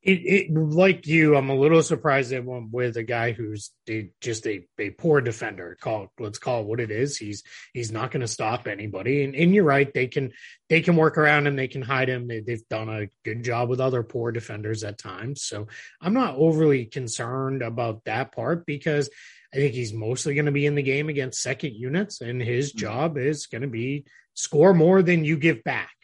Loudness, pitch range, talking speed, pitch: -24 LUFS, 115-150 Hz, 220 wpm, 130 Hz